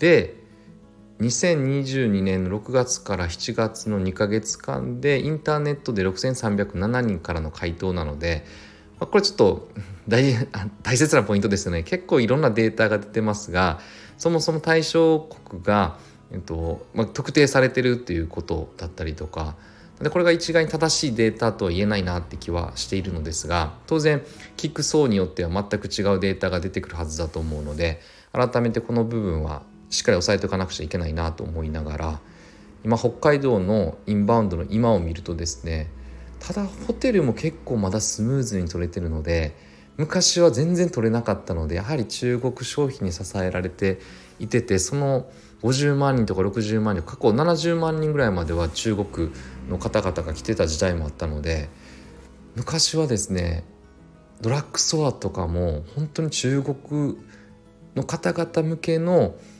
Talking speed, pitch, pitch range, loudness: 325 characters per minute, 105 Hz, 85-130 Hz, -23 LUFS